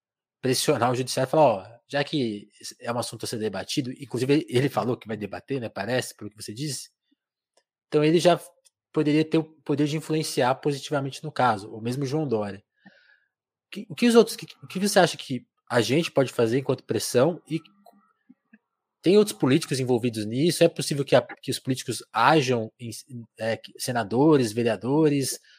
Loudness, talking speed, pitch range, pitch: -25 LUFS, 180 wpm, 120-155 Hz, 135 Hz